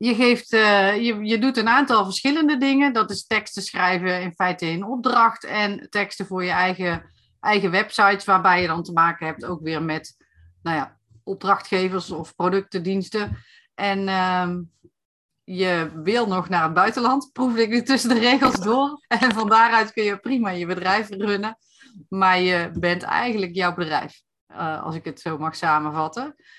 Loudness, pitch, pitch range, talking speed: -21 LUFS, 195 Hz, 180-230 Hz, 175 wpm